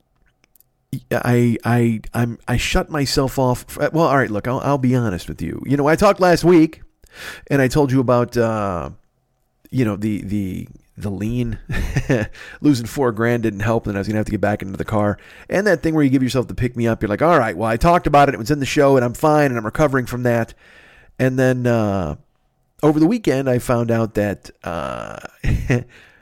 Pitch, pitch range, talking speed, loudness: 120 Hz, 110-140 Hz, 215 wpm, -18 LUFS